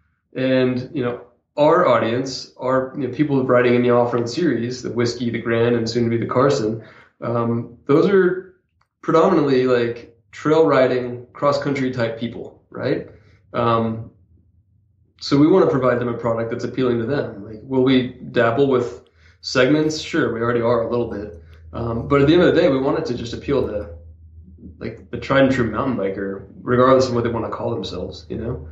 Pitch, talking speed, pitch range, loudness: 120 Hz, 200 wpm, 115-130 Hz, -19 LUFS